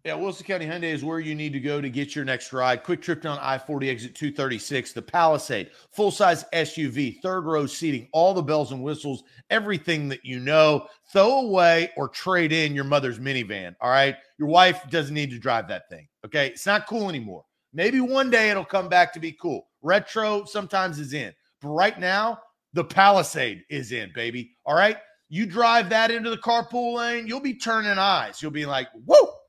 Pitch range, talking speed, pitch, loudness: 140-205 Hz, 205 wpm, 165 Hz, -23 LUFS